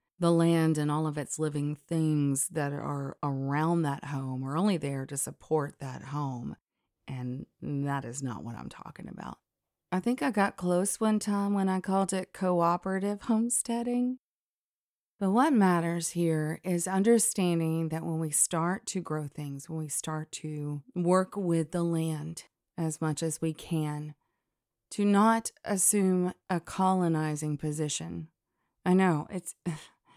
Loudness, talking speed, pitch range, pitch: -30 LUFS, 150 wpm, 150-190 Hz, 165 Hz